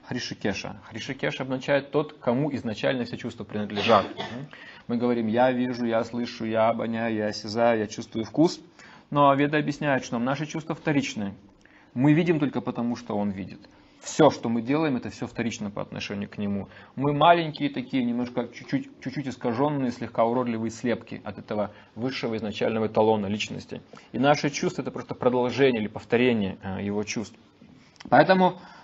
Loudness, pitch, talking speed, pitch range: -26 LUFS, 120 Hz, 155 wpm, 110-140 Hz